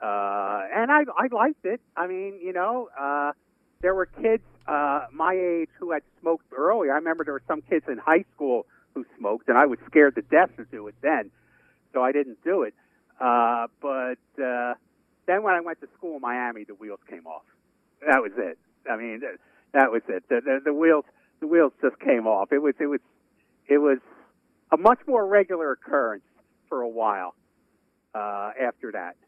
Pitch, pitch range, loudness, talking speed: 150 Hz, 125-185 Hz, -24 LUFS, 200 wpm